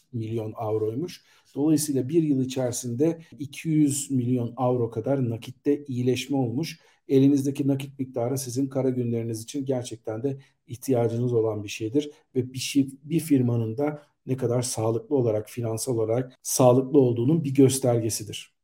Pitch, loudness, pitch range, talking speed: 130 Hz, -25 LUFS, 115-140 Hz, 135 wpm